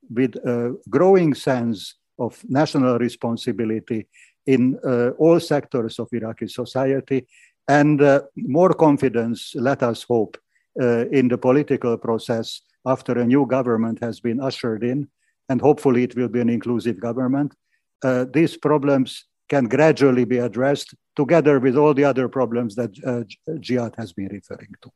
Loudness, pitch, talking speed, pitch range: -20 LUFS, 125 Hz, 150 wpm, 120-140 Hz